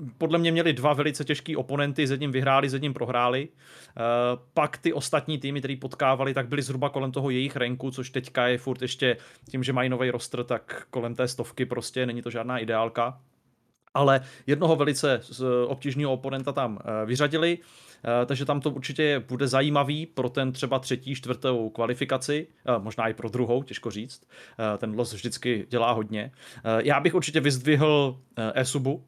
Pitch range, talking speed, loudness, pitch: 120-145 Hz, 165 wpm, -27 LUFS, 130 Hz